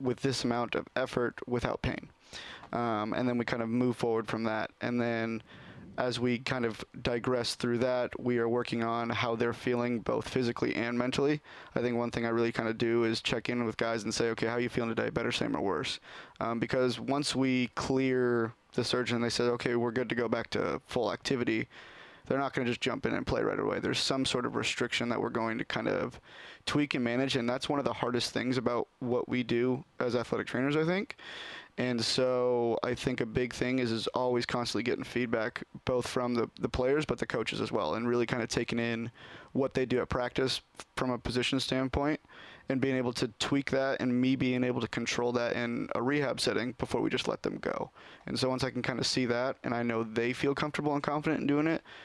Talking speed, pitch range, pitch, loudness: 235 wpm, 120-130 Hz, 125 Hz, -32 LUFS